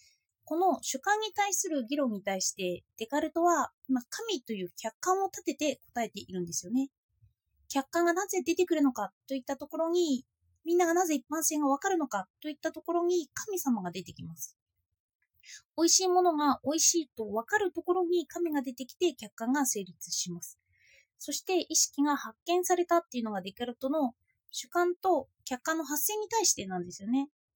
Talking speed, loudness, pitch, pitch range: 355 characters per minute, -30 LUFS, 290 Hz, 220-345 Hz